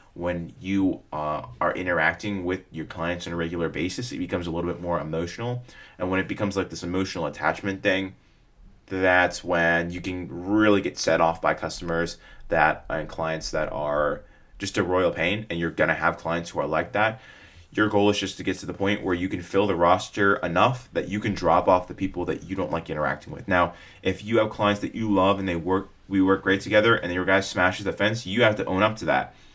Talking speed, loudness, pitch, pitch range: 230 wpm, -25 LUFS, 95 Hz, 85-100 Hz